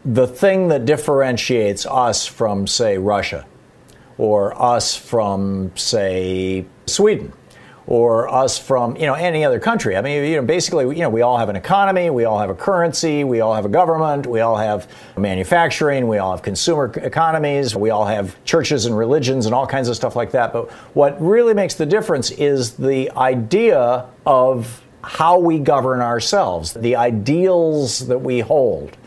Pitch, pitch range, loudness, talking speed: 125 Hz, 110-150 Hz, -17 LUFS, 175 wpm